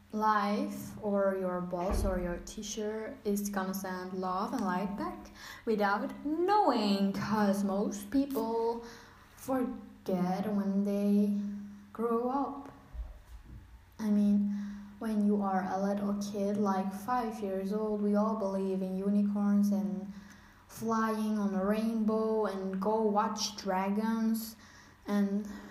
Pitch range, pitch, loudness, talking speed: 195-220 Hz, 205 Hz, -32 LUFS, 120 wpm